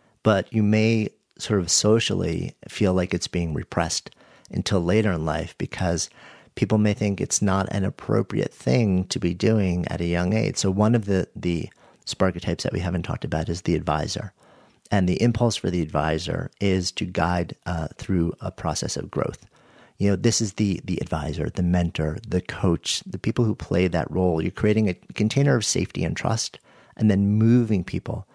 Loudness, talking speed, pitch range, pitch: -24 LUFS, 190 wpm, 90-110 Hz, 95 Hz